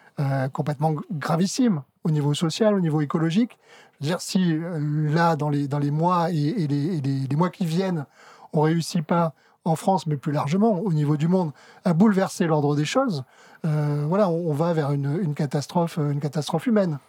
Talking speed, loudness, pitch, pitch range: 205 wpm, -24 LUFS, 160 Hz, 150-180 Hz